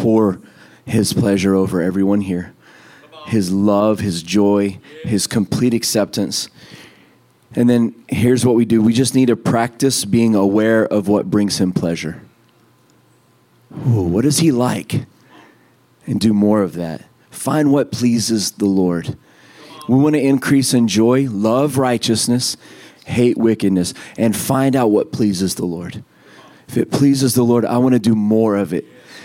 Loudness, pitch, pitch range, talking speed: -16 LUFS, 110 Hz, 100-125 Hz, 155 wpm